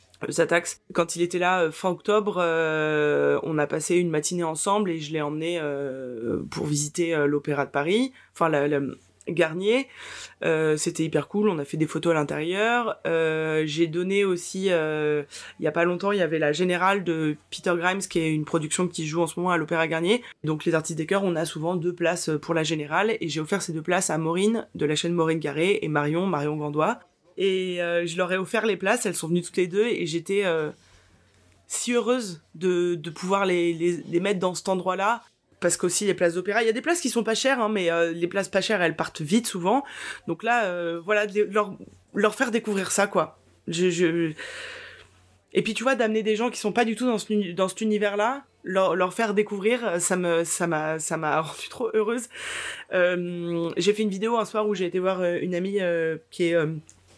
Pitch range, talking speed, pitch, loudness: 160-200 Hz, 225 wpm, 175 Hz, -25 LUFS